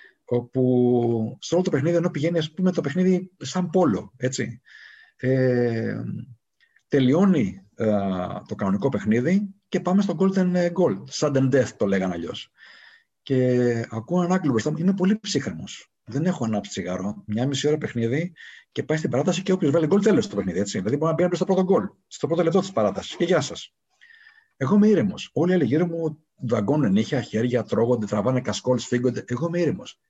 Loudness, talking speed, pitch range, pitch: -23 LUFS, 180 wpm, 115-180 Hz, 140 Hz